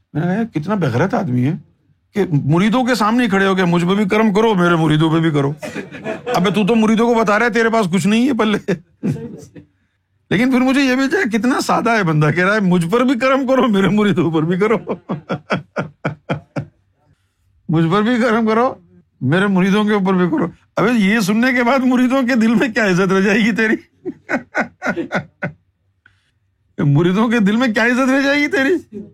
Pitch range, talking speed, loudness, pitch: 170-235 Hz, 185 wpm, -16 LUFS, 205 Hz